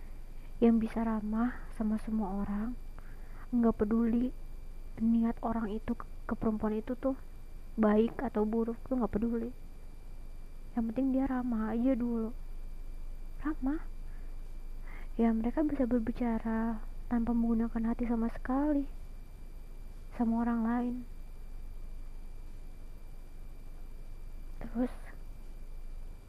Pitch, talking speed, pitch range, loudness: 230 Hz, 95 wpm, 215-245 Hz, -33 LUFS